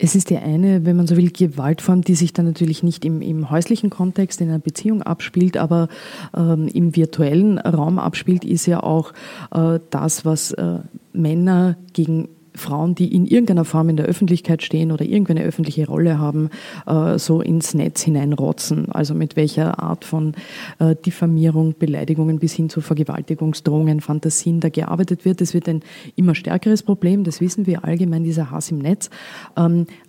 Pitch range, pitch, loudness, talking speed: 160-180 Hz, 165 Hz, -18 LUFS, 170 wpm